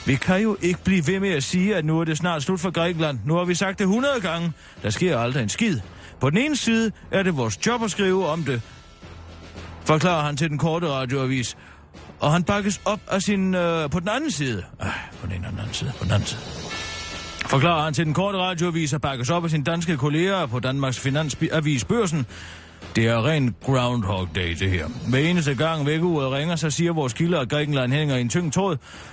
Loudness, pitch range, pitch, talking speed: -23 LUFS, 115-175 Hz, 150 Hz, 220 wpm